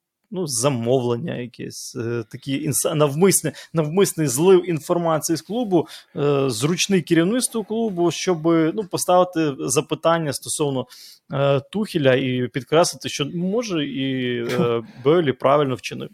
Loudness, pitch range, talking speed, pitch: -21 LUFS, 135-175 Hz, 120 wpm, 155 Hz